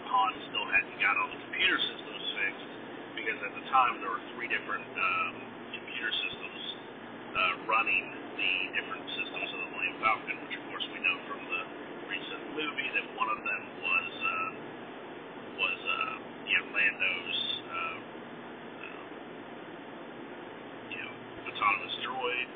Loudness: -31 LUFS